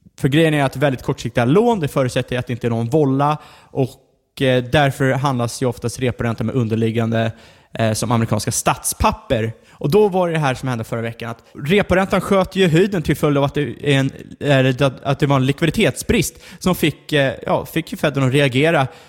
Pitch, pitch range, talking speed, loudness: 135 Hz, 120-155 Hz, 190 wpm, -18 LUFS